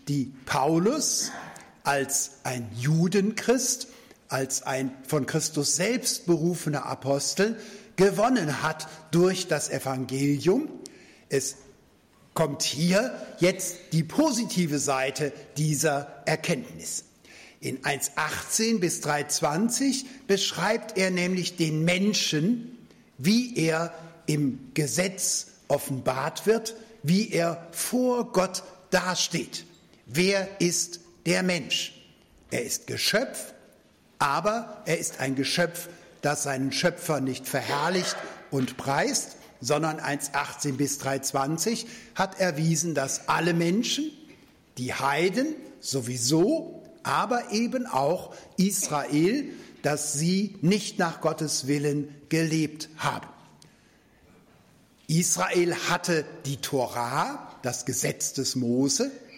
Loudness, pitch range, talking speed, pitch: -27 LUFS, 145-200 Hz, 100 wpm, 165 Hz